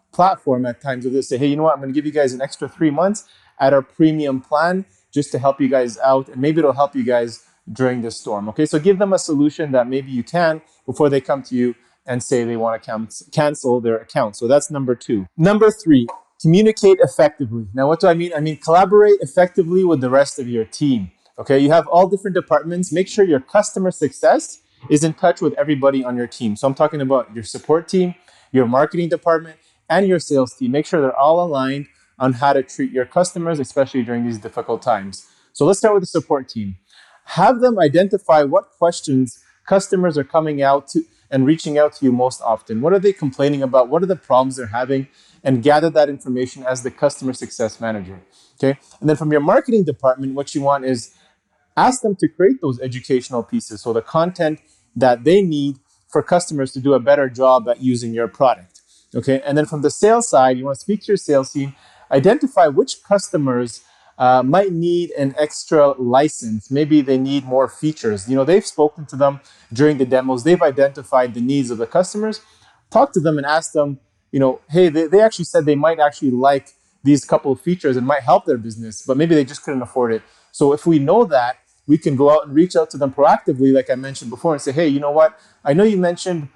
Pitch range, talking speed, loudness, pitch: 130-165 Hz, 220 wpm, -17 LUFS, 140 Hz